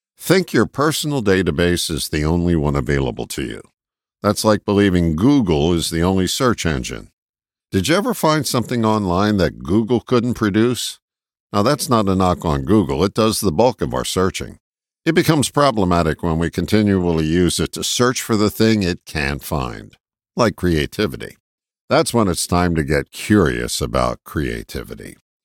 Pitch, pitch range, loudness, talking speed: 95 Hz, 80-115 Hz, -18 LUFS, 165 wpm